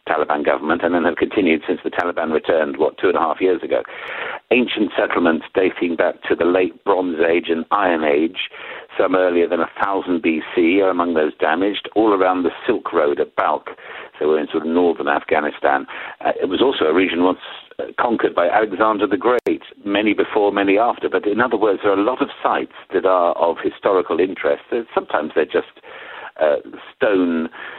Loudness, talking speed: -18 LUFS, 190 wpm